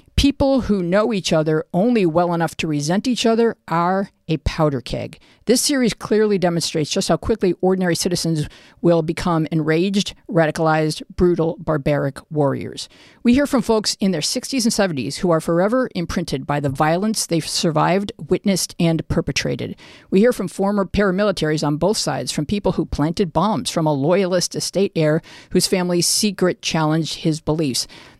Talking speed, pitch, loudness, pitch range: 165 wpm, 175 Hz, -19 LUFS, 160-200 Hz